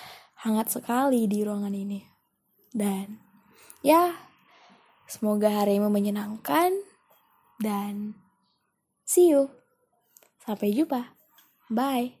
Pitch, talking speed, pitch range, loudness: 215 Hz, 80 wpm, 205-265 Hz, -26 LUFS